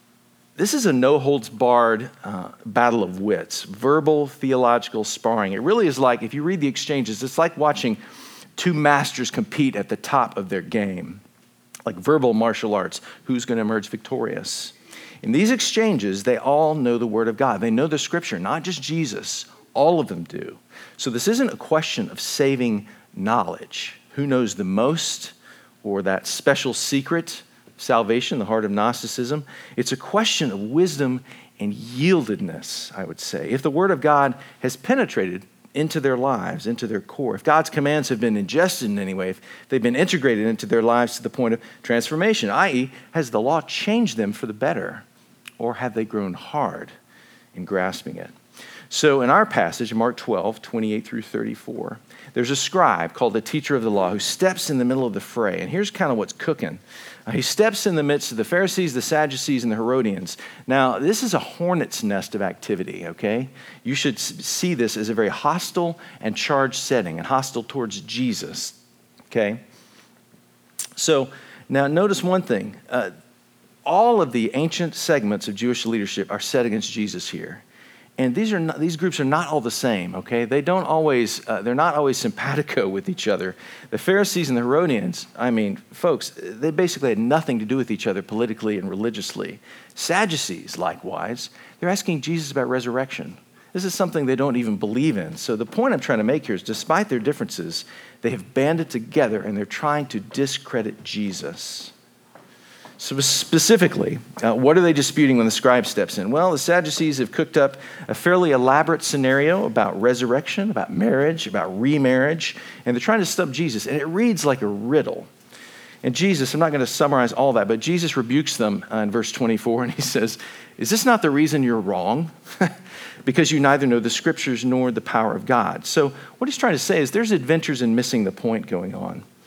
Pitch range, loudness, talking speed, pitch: 115-165 Hz, -22 LUFS, 190 wpm, 135 Hz